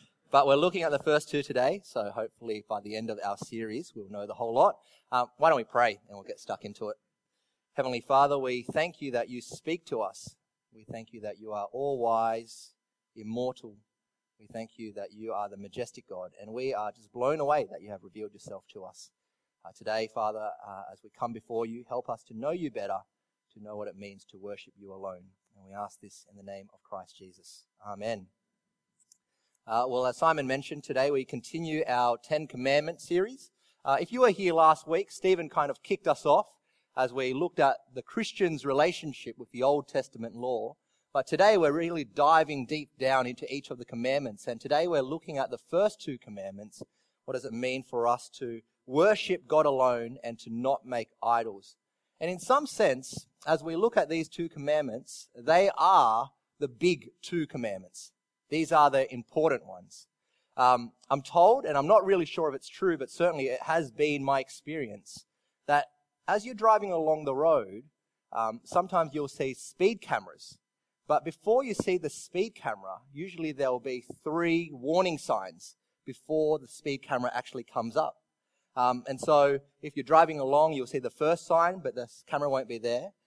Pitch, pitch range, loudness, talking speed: 135 Hz, 115-160 Hz, -29 LUFS, 195 wpm